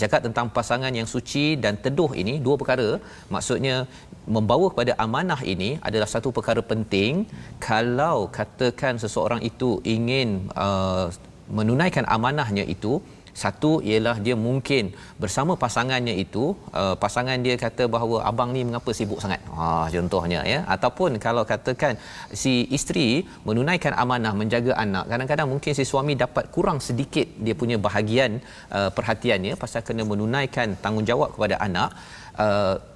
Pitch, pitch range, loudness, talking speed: 120 Hz, 105-130 Hz, -24 LUFS, 140 wpm